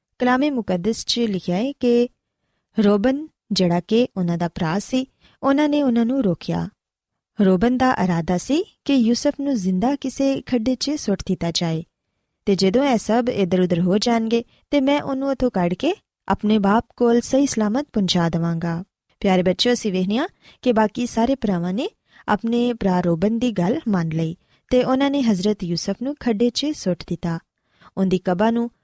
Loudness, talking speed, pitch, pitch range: -21 LUFS, 165 wpm, 225 Hz, 185-255 Hz